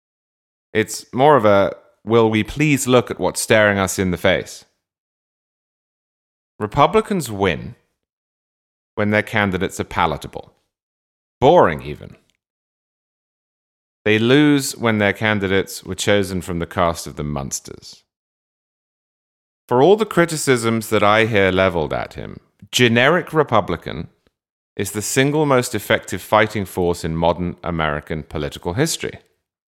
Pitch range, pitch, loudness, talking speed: 90-120 Hz, 105 Hz, -18 LUFS, 125 wpm